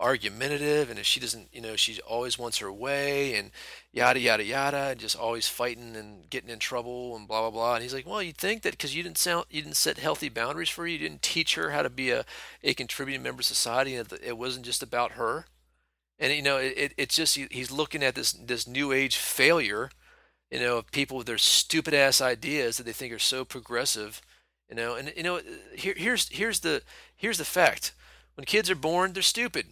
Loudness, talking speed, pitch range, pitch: -27 LUFS, 230 wpm, 115-155 Hz, 130 Hz